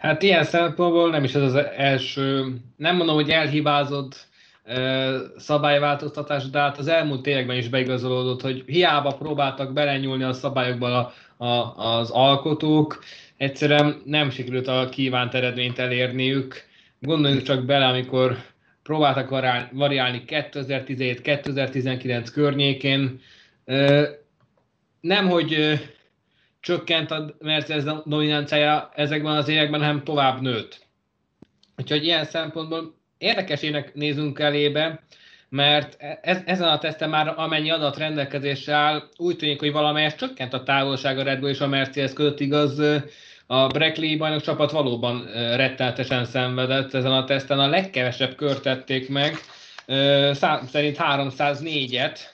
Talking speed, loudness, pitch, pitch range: 120 wpm, -22 LUFS, 145 Hz, 130-150 Hz